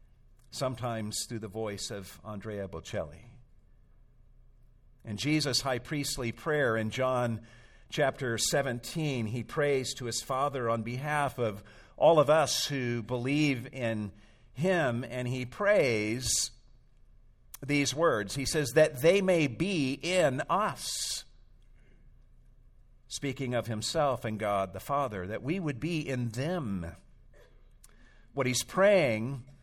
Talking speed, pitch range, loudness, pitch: 120 wpm, 110-145 Hz, -30 LUFS, 125 Hz